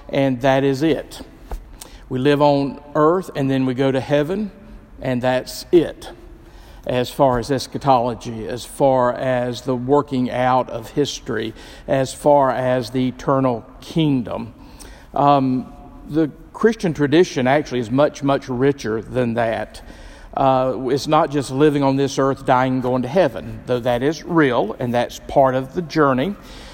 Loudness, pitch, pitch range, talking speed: -19 LUFS, 135 Hz, 125-145 Hz, 155 wpm